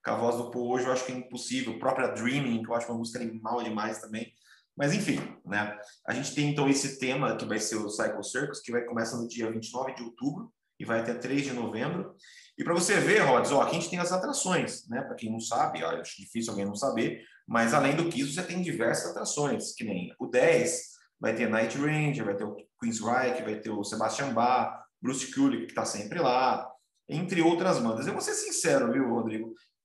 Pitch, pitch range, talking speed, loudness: 125 Hz, 115-145 Hz, 230 wpm, -29 LUFS